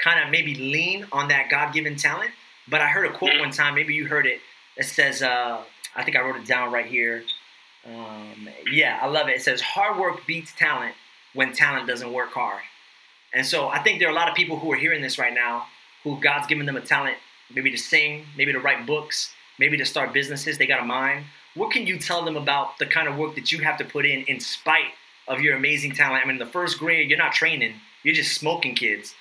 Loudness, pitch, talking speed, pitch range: -22 LUFS, 145 Hz, 240 wpm, 130-155 Hz